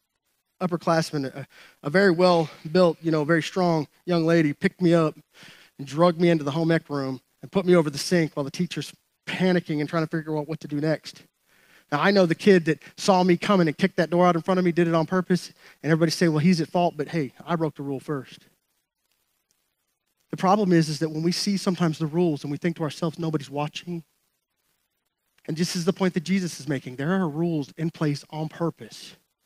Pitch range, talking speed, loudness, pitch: 155-180 Hz, 230 wpm, -24 LUFS, 165 Hz